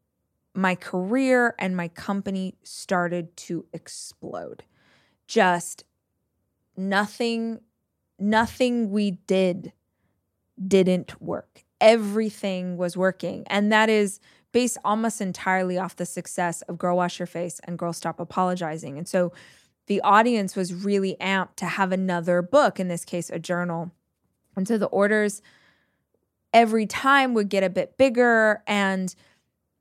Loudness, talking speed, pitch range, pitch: -24 LUFS, 130 wpm, 175-210 Hz, 190 Hz